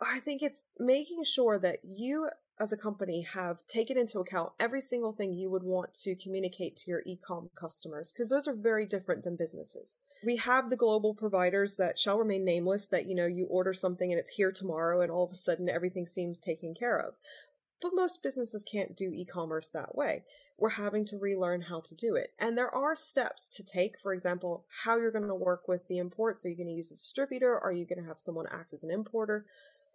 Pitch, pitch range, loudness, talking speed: 195 Hz, 180-235 Hz, -33 LUFS, 215 wpm